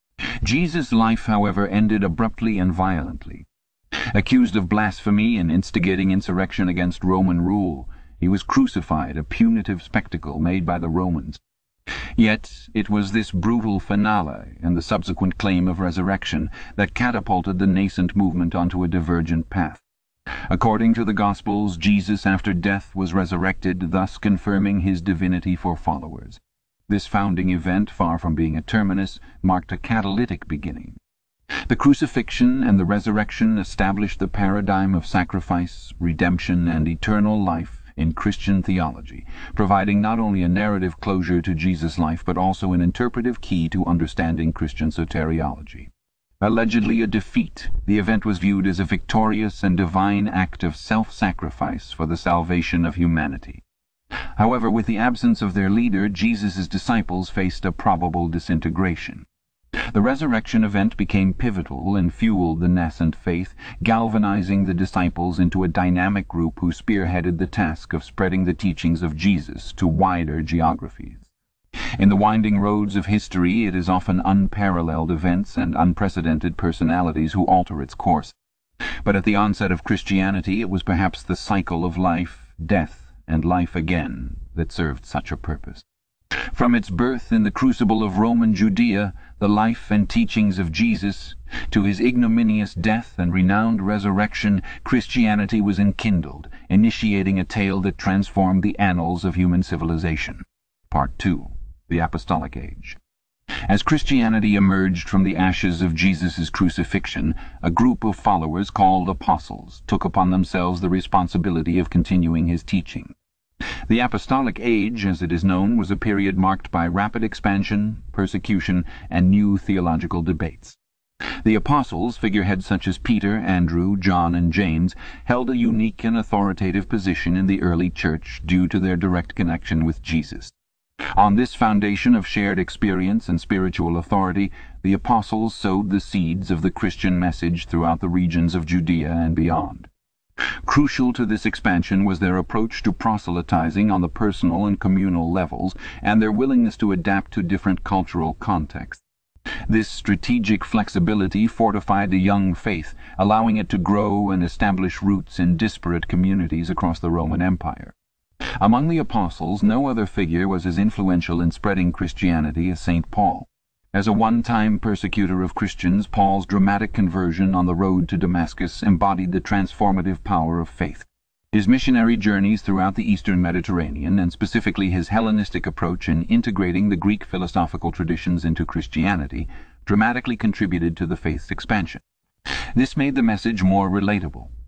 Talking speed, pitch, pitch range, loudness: 150 wpm, 95 Hz, 85-105 Hz, -21 LUFS